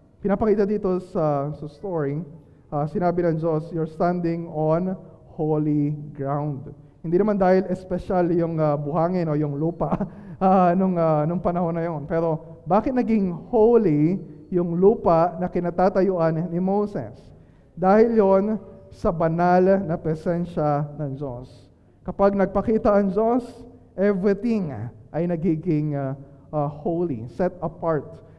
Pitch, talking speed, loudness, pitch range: 170 Hz, 130 wpm, -22 LUFS, 150-190 Hz